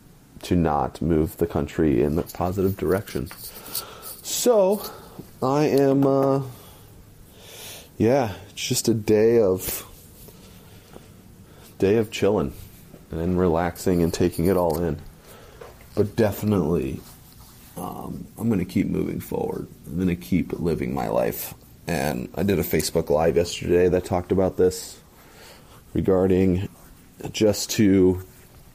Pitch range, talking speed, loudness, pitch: 90-110 Hz, 125 wpm, -23 LUFS, 95 Hz